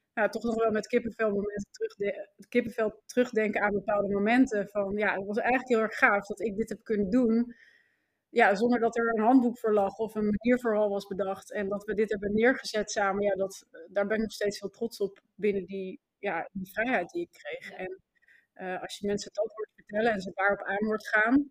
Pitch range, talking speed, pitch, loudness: 200-230 Hz, 220 wpm, 210 Hz, -29 LUFS